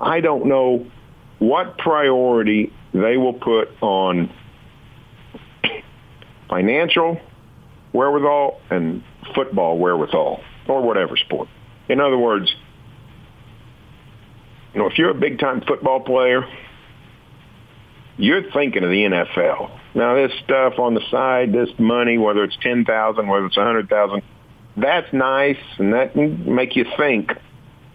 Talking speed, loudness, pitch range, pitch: 125 wpm, -18 LUFS, 105-130 Hz, 120 Hz